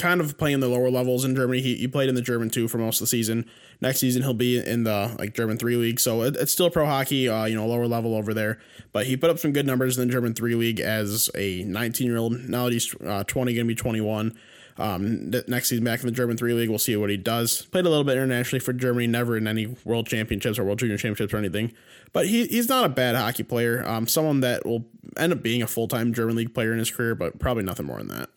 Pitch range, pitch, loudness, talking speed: 115-125 Hz, 120 Hz, -24 LUFS, 275 wpm